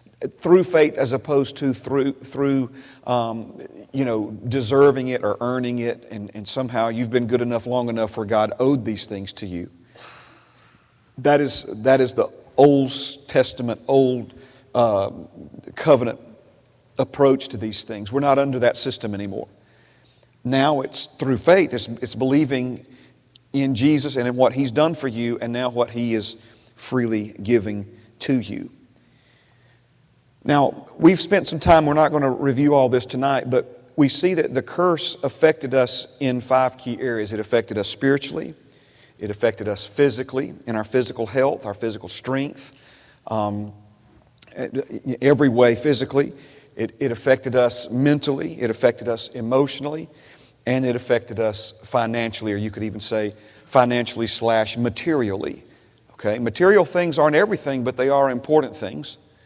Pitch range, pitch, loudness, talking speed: 115-140 Hz, 125 Hz, -21 LUFS, 155 wpm